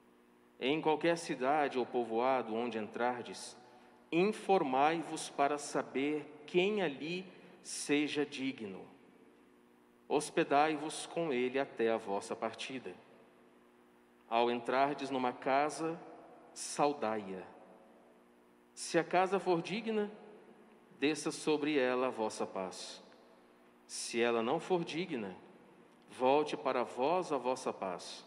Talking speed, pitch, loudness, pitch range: 100 wpm, 130 Hz, -35 LUFS, 110-155 Hz